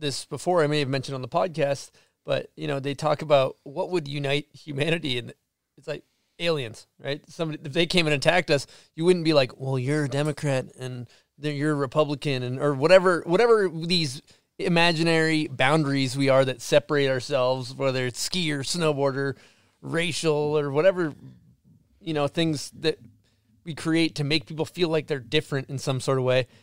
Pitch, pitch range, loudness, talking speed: 150 Hz, 135-160 Hz, -24 LUFS, 185 wpm